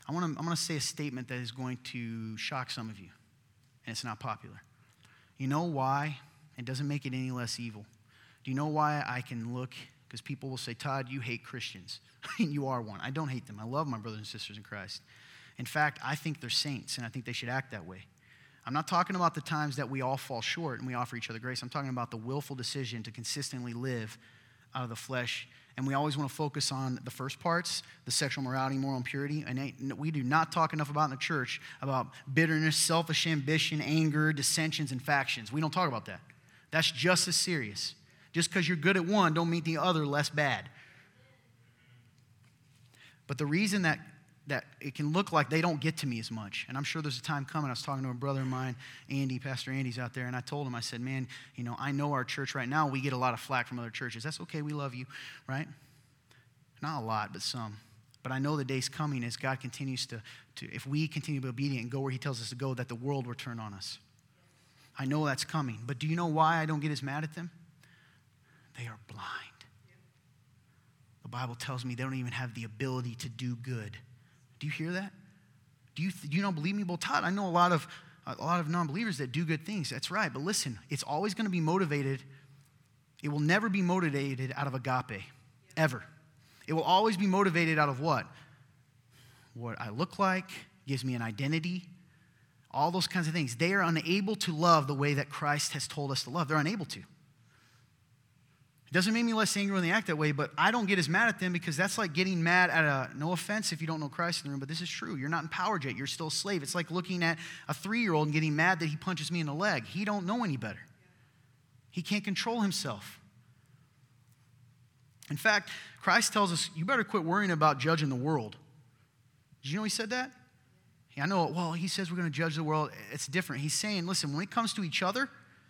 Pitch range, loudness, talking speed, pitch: 125-160 Hz, -32 LUFS, 235 wpm, 140 Hz